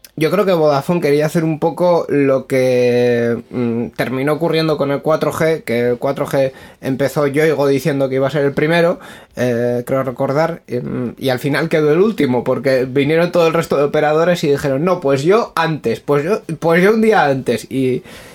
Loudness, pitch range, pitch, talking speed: -16 LUFS, 130-160 Hz, 145 Hz, 195 wpm